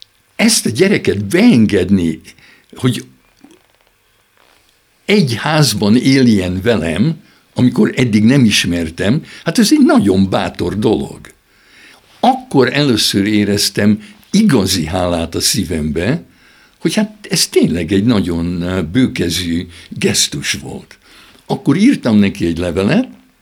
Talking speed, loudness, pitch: 100 wpm, -13 LUFS, 105 Hz